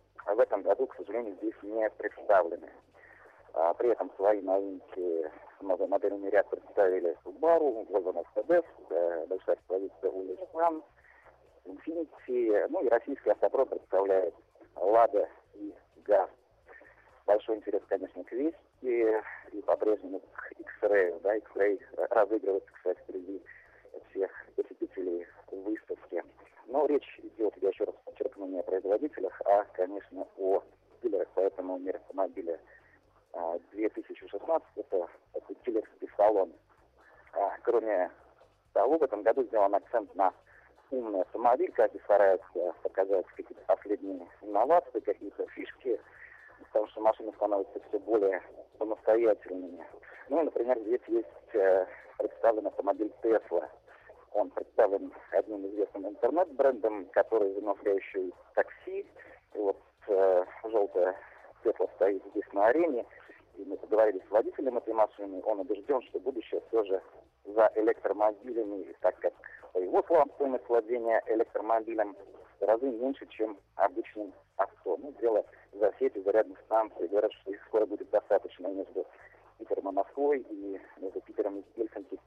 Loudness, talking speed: -31 LUFS, 125 wpm